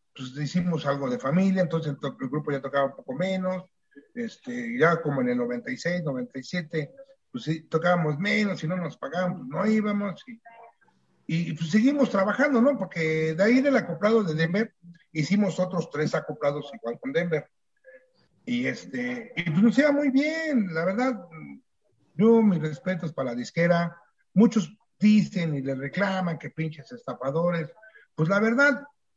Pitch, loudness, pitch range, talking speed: 180 Hz, -26 LUFS, 155-220 Hz, 160 wpm